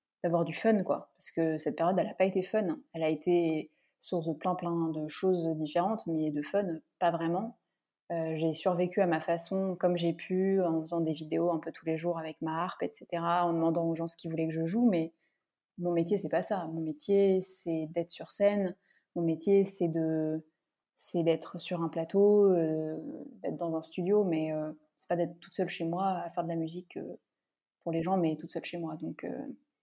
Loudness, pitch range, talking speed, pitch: -32 LUFS, 160-185 Hz, 225 wpm, 170 Hz